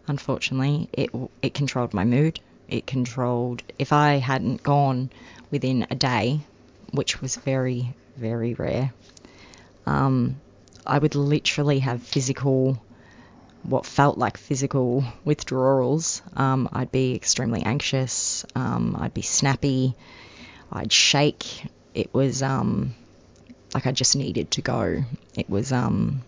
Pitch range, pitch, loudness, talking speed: 120-135 Hz, 130 Hz, -24 LUFS, 125 wpm